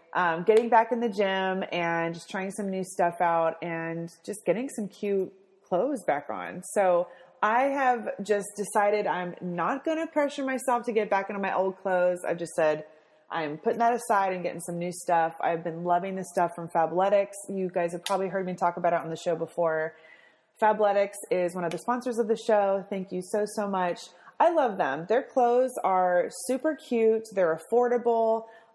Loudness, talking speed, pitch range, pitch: -27 LUFS, 200 wpm, 175-225 Hz, 190 Hz